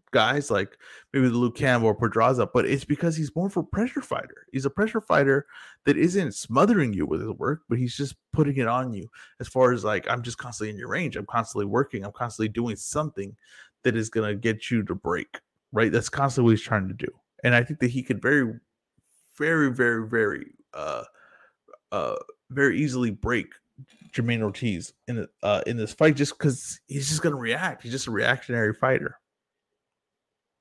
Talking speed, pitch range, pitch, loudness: 195 wpm, 115-145 Hz, 125 Hz, -25 LUFS